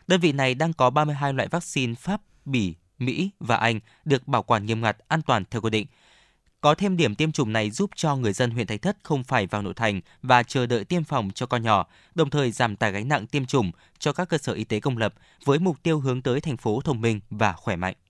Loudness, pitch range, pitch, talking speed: -25 LUFS, 110-150 Hz, 125 Hz, 255 wpm